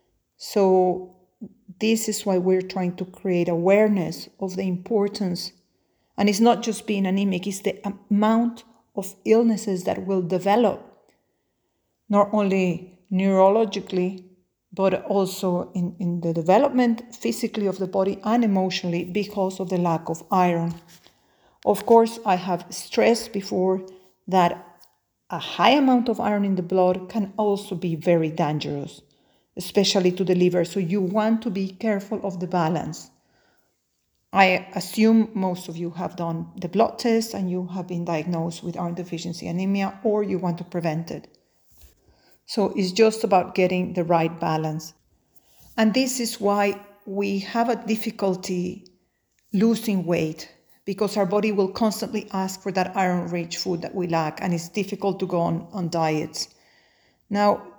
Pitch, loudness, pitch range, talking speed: 190 Hz, -23 LUFS, 180-205 Hz, 150 wpm